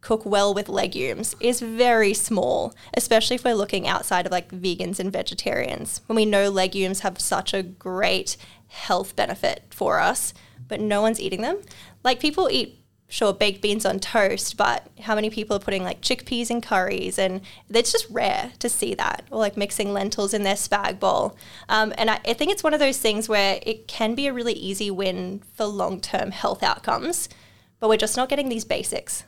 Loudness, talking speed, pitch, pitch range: -23 LUFS, 200 wpm, 215 Hz, 195-240 Hz